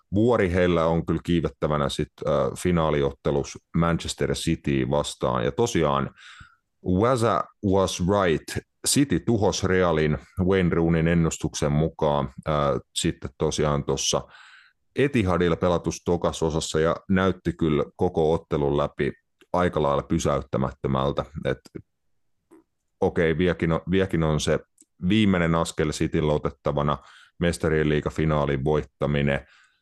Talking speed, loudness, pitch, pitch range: 105 wpm, -24 LUFS, 80 Hz, 75-90 Hz